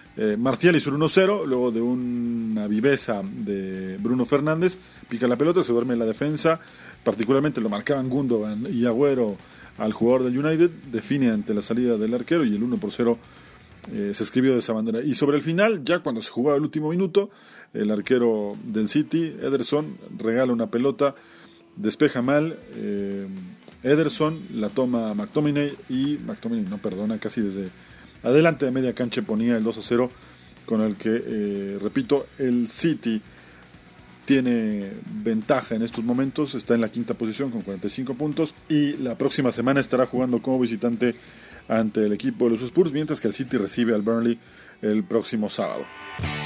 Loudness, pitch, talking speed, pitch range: -24 LUFS, 125 Hz, 165 wpm, 110-145 Hz